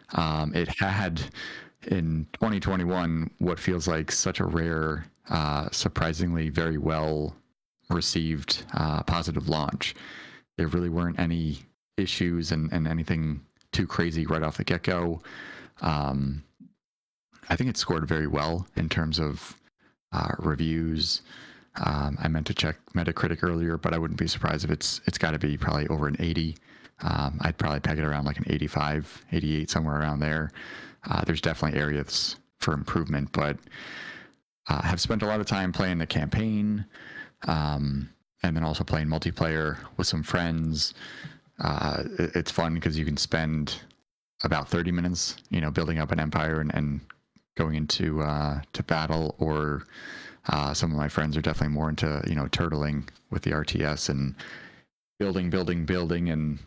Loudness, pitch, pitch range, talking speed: -28 LUFS, 80 Hz, 75-85 Hz, 160 wpm